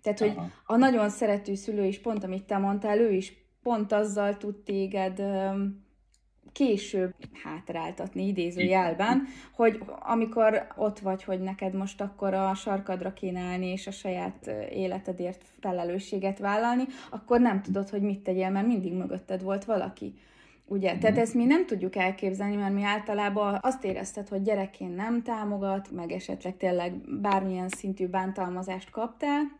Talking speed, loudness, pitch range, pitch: 145 wpm, -29 LUFS, 190-215 Hz, 200 Hz